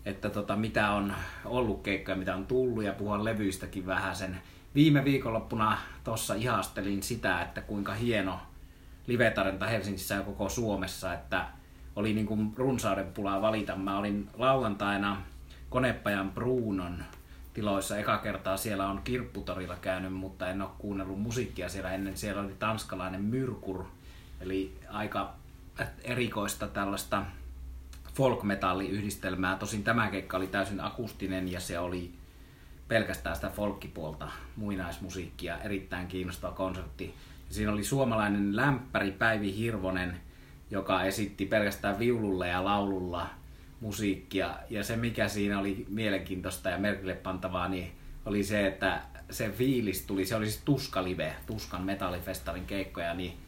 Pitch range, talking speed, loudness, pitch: 95-105 Hz, 130 wpm, -32 LUFS, 100 Hz